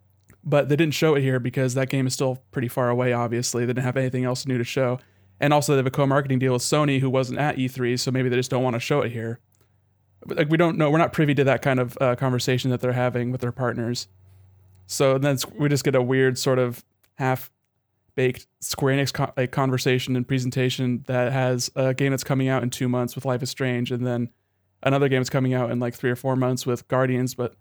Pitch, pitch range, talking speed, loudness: 130 Hz, 120-135 Hz, 245 wpm, -23 LUFS